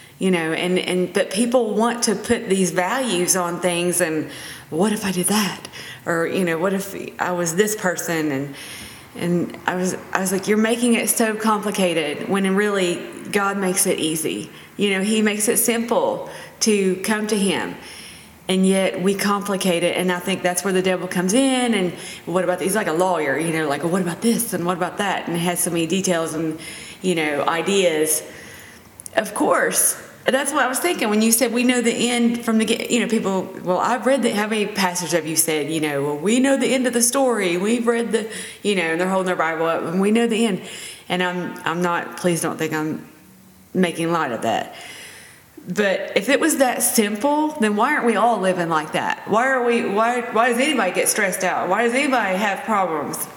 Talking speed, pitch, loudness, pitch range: 220 wpm, 190 Hz, -20 LUFS, 175-225 Hz